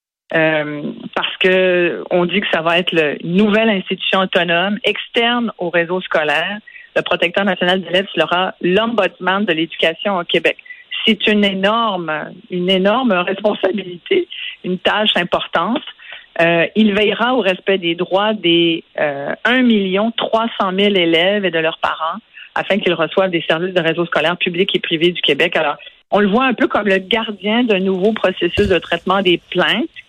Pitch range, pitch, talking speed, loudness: 175-215 Hz, 190 Hz, 170 wpm, -16 LUFS